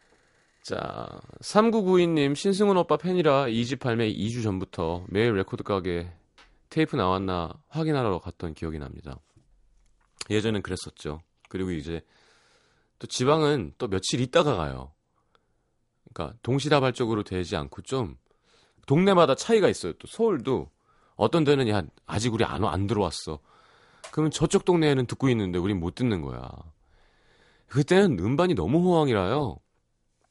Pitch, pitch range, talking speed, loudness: 110 Hz, 90-150 Hz, 280 characters per minute, -25 LUFS